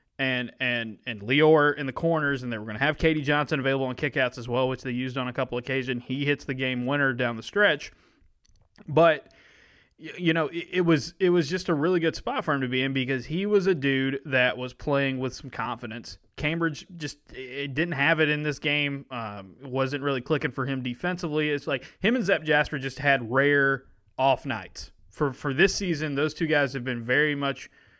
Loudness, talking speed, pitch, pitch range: -26 LUFS, 220 wpm, 140 Hz, 130-155 Hz